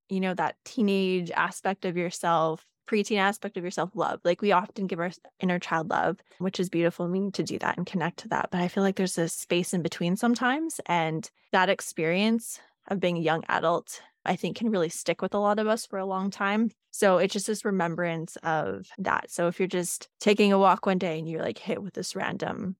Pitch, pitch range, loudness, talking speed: 185 Hz, 175-200 Hz, -27 LUFS, 230 wpm